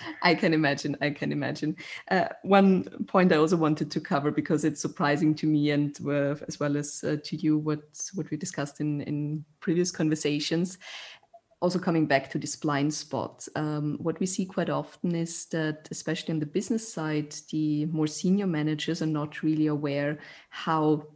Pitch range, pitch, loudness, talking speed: 150-165 Hz, 155 Hz, -28 LUFS, 180 wpm